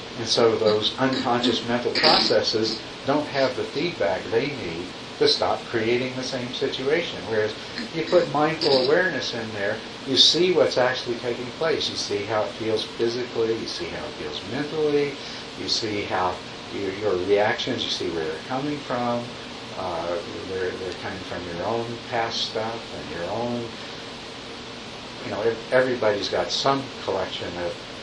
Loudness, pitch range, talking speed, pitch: -24 LUFS, 115-135 Hz, 155 wpm, 120 Hz